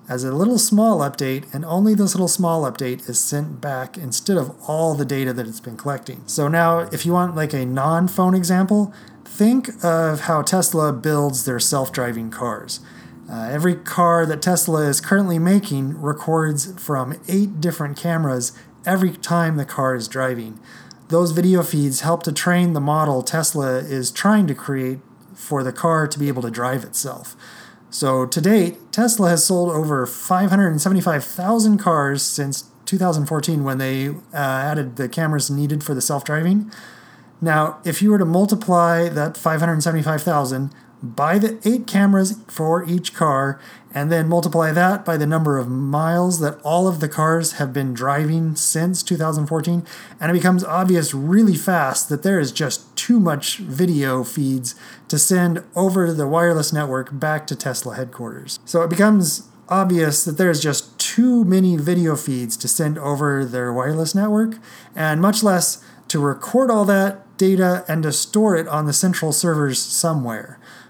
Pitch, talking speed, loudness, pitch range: 160 Hz, 165 wpm, -19 LUFS, 140-180 Hz